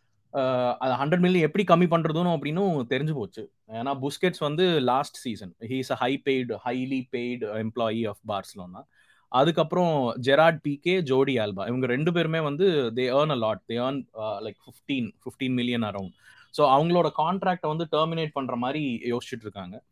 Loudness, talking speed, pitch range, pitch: -26 LUFS, 150 wpm, 120-165 Hz, 135 Hz